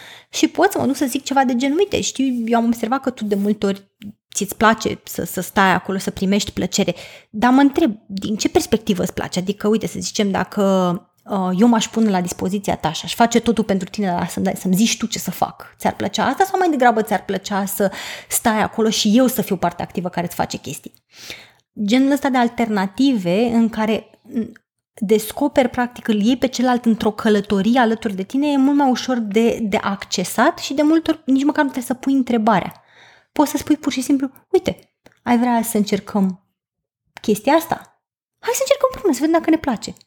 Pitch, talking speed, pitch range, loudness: 225 Hz, 215 wpm, 200-270 Hz, -19 LUFS